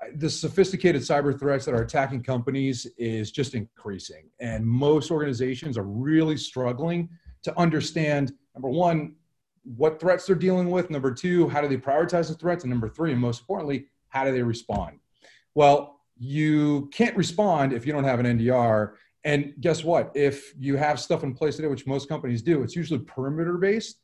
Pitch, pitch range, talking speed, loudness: 145 Hz, 130-160 Hz, 180 wpm, -25 LUFS